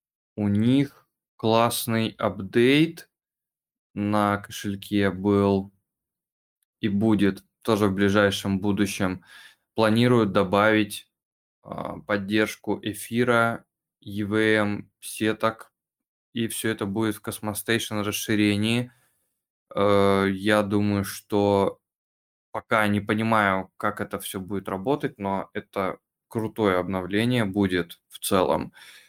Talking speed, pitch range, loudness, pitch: 95 wpm, 100-110 Hz, -24 LUFS, 105 Hz